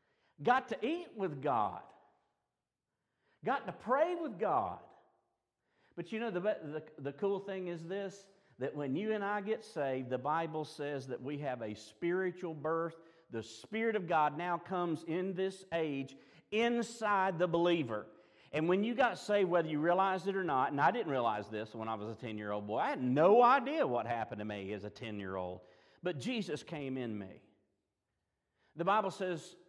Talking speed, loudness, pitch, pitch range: 190 wpm, -35 LUFS, 165 Hz, 120-190 Hz